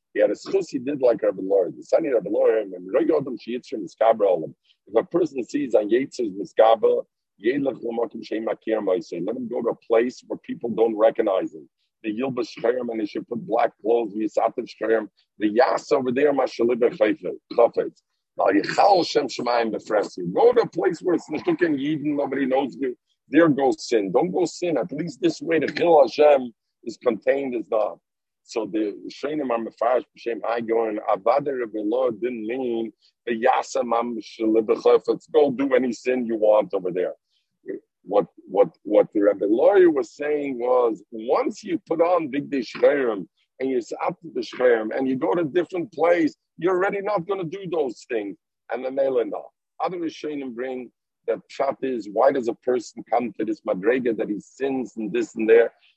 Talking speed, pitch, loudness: 185 wpm, 210 Hz, -23 LUFS